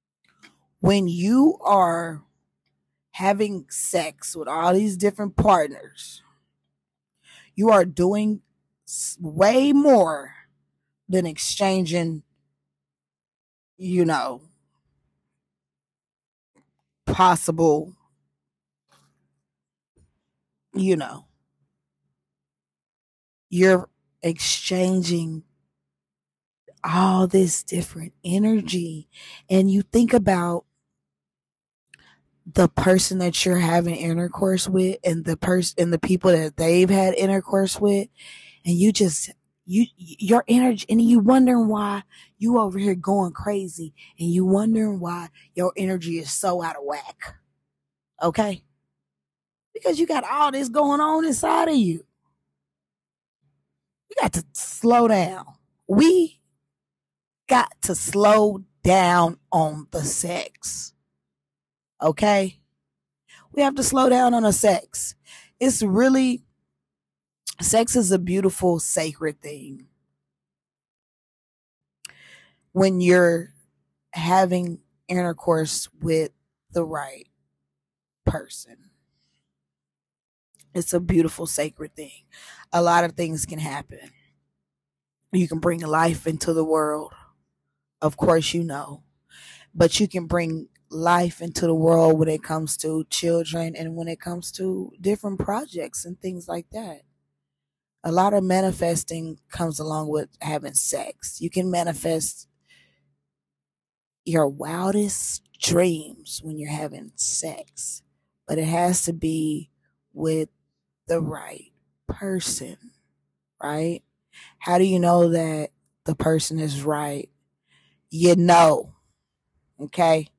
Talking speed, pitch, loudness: 105 wpm, 165 Hz, -21 LUFS